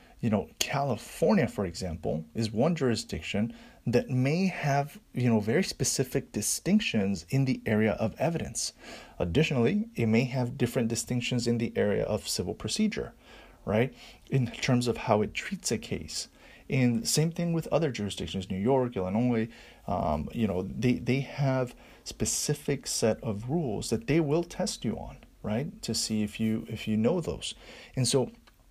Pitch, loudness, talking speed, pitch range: 125 Hz, -29 LUFS, 165 wpm, 110-140 Hz